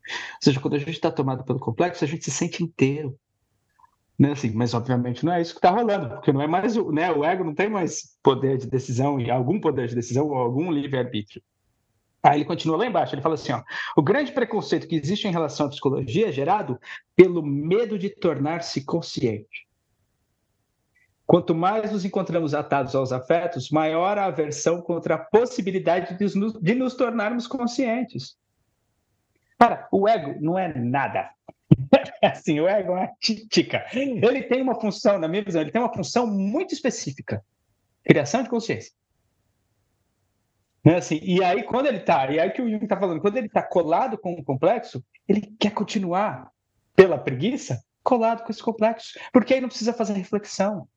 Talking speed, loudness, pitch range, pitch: 185 wpm, -23 LUFS, 135-210 Hz, 170 Hz